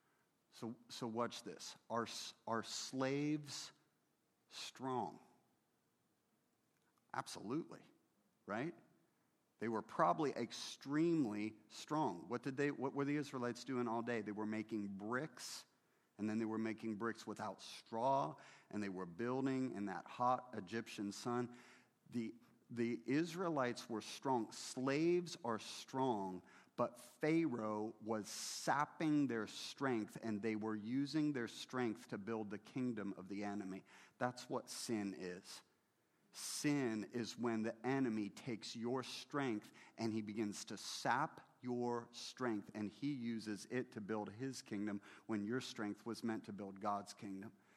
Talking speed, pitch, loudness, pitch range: 135 wpm, 115 Hz, -43 LUFS, 105-130 Hz